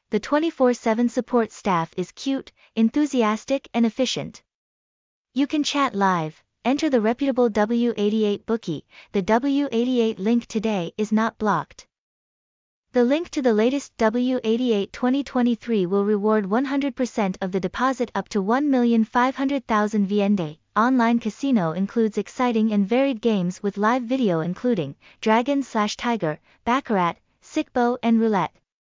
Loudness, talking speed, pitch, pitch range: -22 LUFS, 125 wpm, 230 Hz, 210-255 Hz